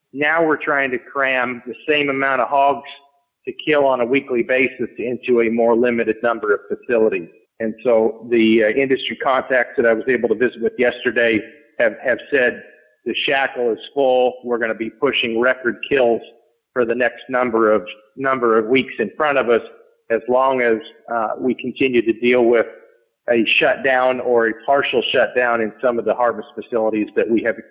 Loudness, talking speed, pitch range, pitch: -18 LUFS, 190 wpm, 115-135 Hz, 125 Hz